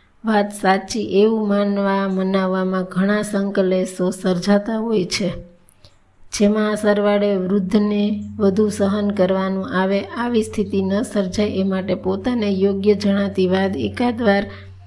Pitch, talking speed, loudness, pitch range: 200 Hz, 115 wpm, -19 LUFS, 190-210 Hz